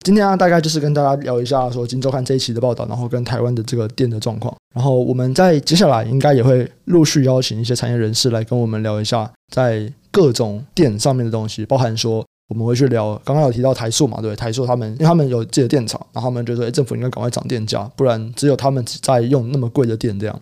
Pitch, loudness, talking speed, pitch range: 125 Hz, -17 LUFS, 400 characters per minute, 115-140 Hz